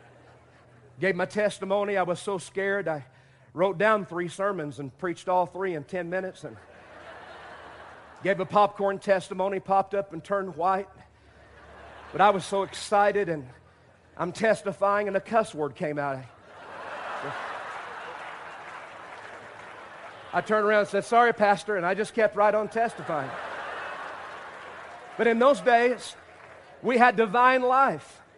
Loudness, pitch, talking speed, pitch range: -26 LUFS, 195 Hz, 140 wpm, 170-210 Hz